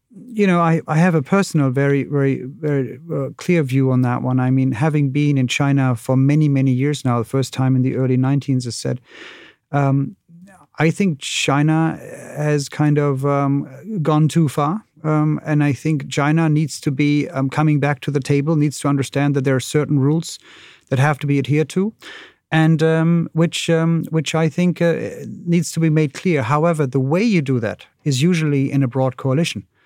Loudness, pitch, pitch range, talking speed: -18 LUFS, 145 Hz, 135-160 Hz, 200 wpm